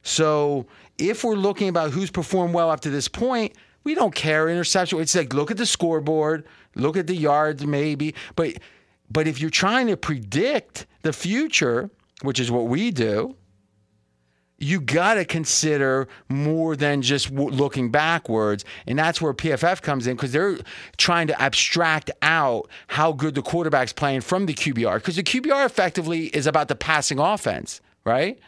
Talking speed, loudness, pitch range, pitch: 170 wpm, -22 LUFS, 140-175 Hz, 155 Hz